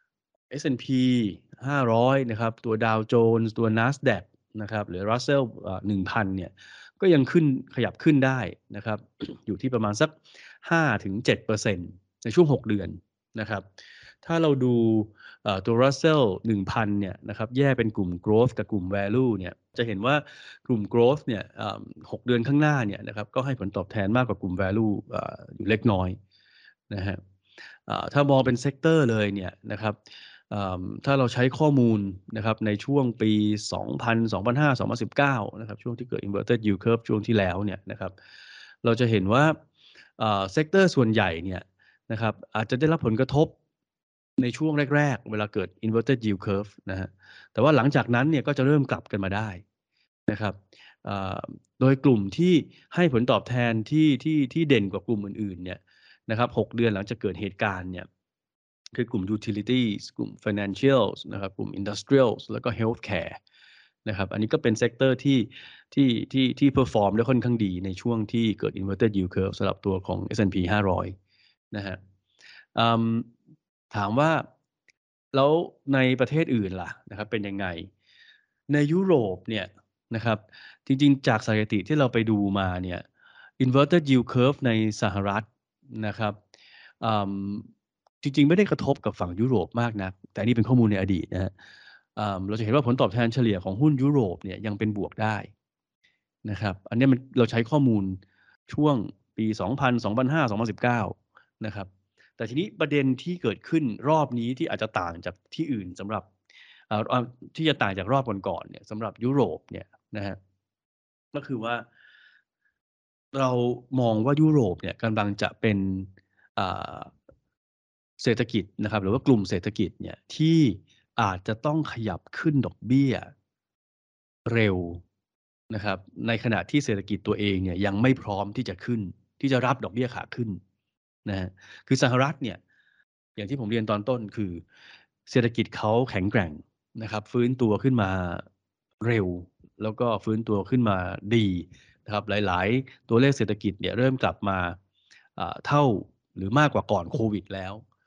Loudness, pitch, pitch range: -26 LUFS, 110 Hz, 100-130 Hz